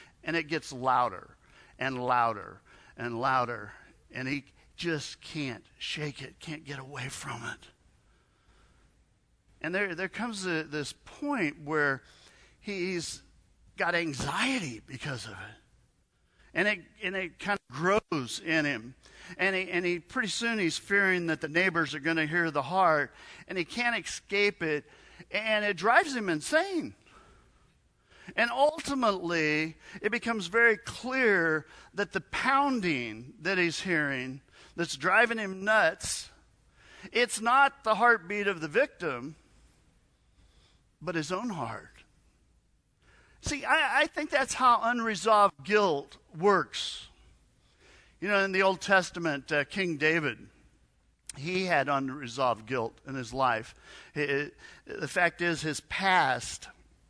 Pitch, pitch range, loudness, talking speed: 170 Hz, 140-205 Hz, -29 LUFS, 135 wpm